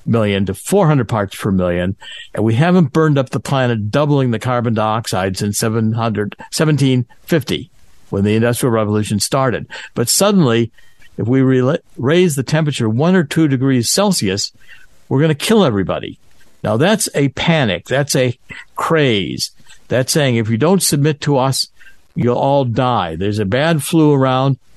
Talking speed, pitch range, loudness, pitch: 155 wpm, 110-150 Hz, -15 LUFS, 130 Hz